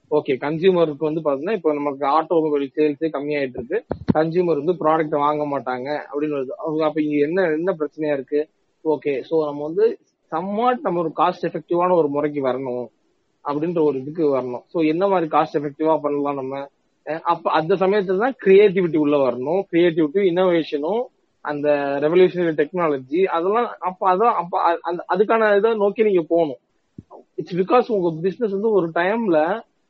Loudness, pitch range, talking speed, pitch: -20 LUFS, 150-190 Hz, 145 wpm, 160 Hz